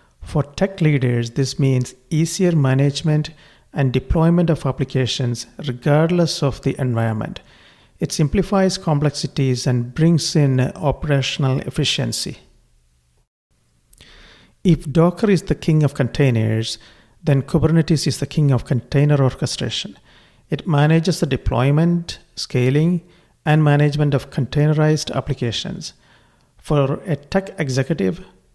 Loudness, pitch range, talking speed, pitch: -19 LUFS, 130-160 Hz, 110 wpm, 145 Hz